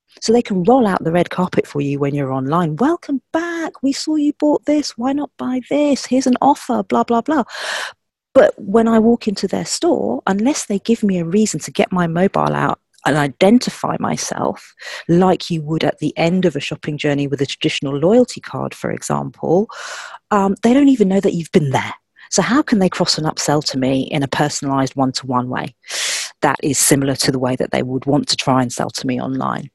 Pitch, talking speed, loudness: 185 Hz, 220 wpm, -17 LUFS